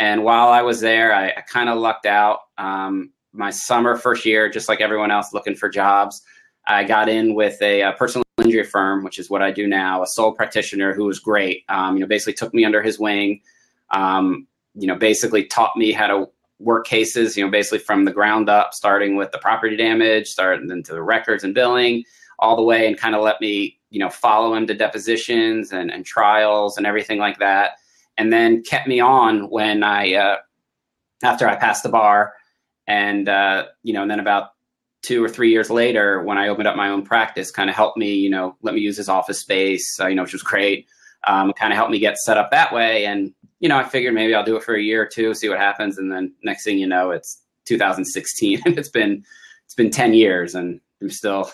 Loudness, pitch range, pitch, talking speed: -18 LUFS, 100-115 Hz, 105 Hz, 230 wpm